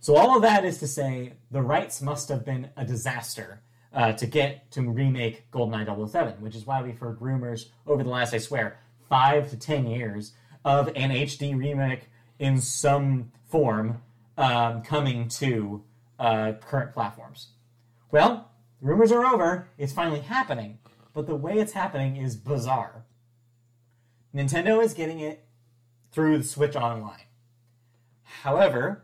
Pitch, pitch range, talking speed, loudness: 120 Hz, 115-140 Hz, 150 wpm, -26 LUFS